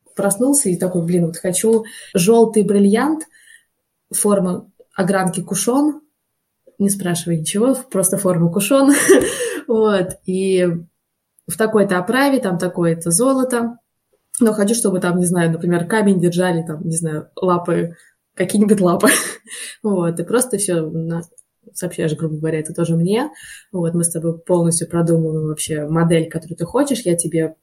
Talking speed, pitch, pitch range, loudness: 140 wpm, 185 Hz, 170-225 Hz, -17 LUFS